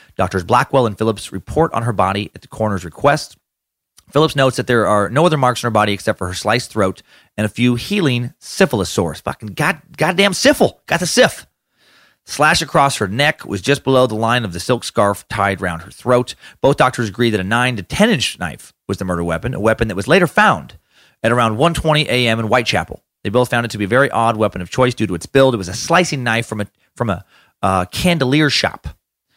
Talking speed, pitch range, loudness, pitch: 230 wpm, 105-135 Hz, -16 LUFS, 120 Hz